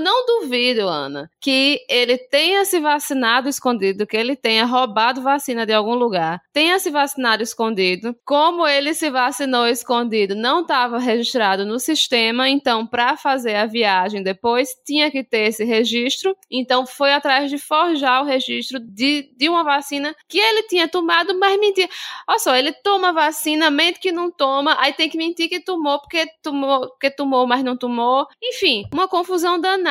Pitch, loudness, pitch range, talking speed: 275 Hz, -18 LUFS, 240-320 Hz, 170 wpm